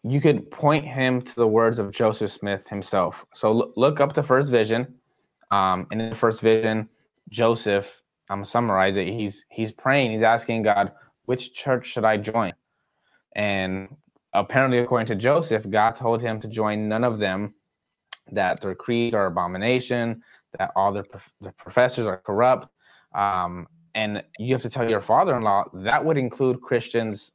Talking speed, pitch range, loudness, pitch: 175 wpm, 100-125 Hz, -23 LUFS, 110 Hz